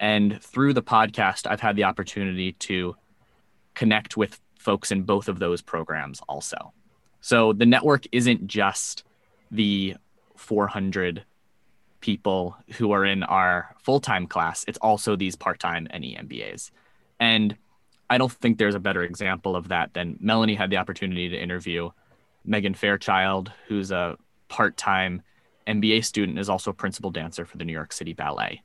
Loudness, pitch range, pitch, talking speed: -24 LUFS, 95-110 Hz, 100 Hz, 155 wpm